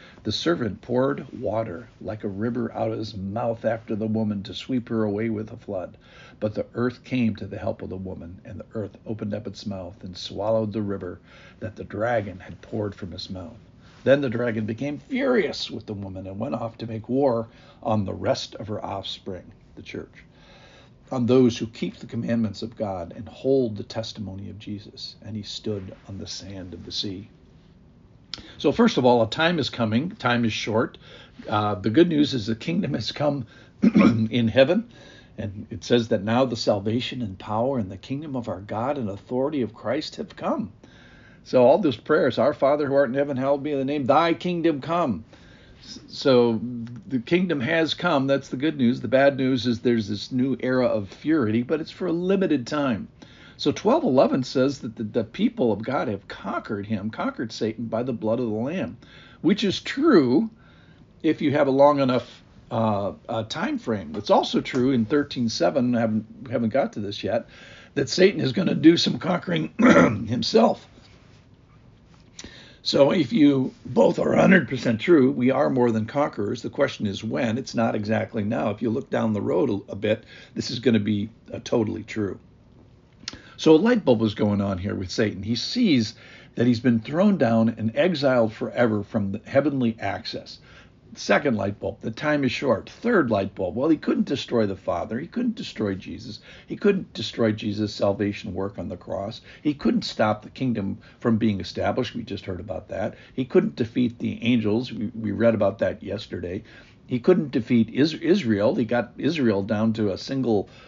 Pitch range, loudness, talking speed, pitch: 105-135 Hz, -24 LUFS, 195 wpm, 115 Hz